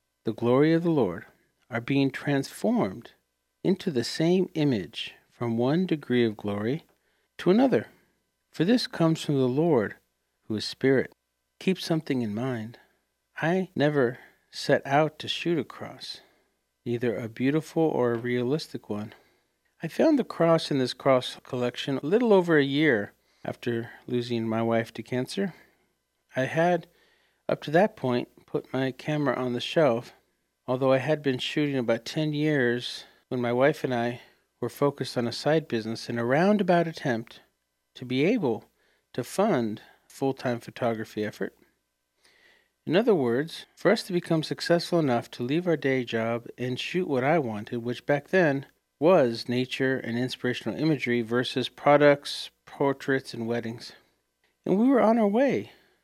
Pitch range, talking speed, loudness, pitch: 120-155 Hz, 160 wpm, -26 LUFS, 130 Hz